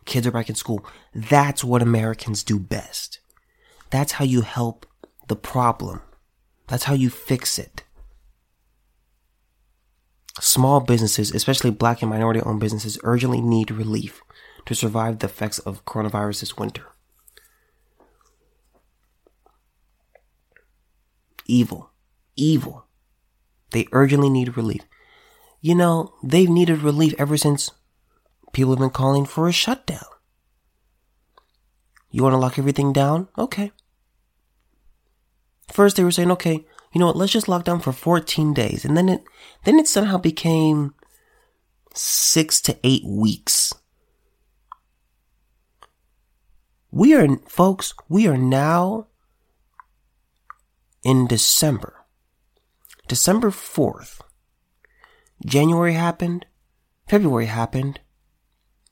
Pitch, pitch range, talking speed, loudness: 135 Hz, 115-170 Hz, 110 wpm, -20 LUFS